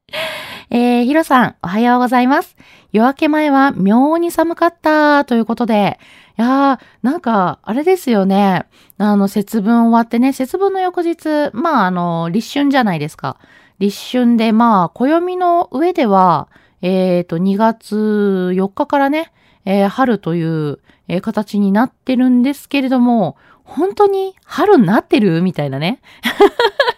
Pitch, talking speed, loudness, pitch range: 240 Hz, 270 characters per minute, -14 LUFS, 200-290 Hz